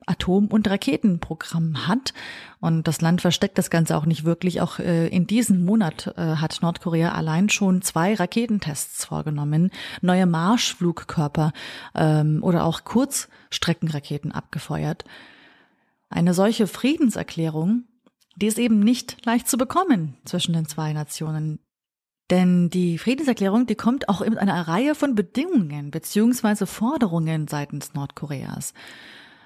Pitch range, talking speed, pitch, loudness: 160-220 Hz, 125 wpm, 180 Hz, -22 LUFS